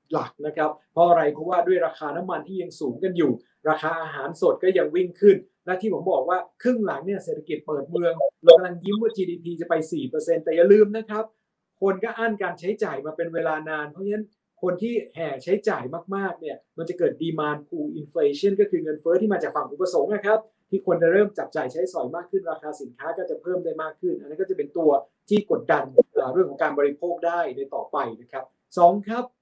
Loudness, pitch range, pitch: -24 LUFS, 165-215 Hz, 180 Hz